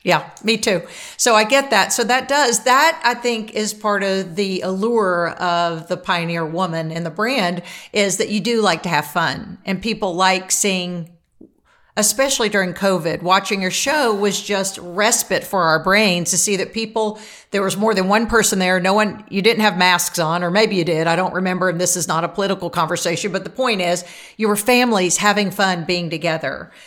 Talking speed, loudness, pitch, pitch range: 205 wpm, -18 LUFS, 195 Hz, 180-215 Hz